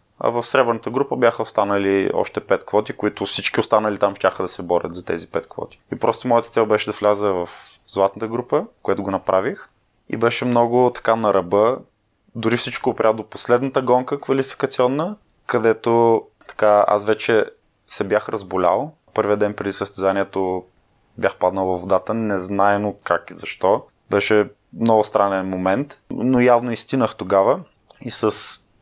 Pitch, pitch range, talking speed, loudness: 110 Hz, 100-120 Hz, 160 wpm, -20 LUFS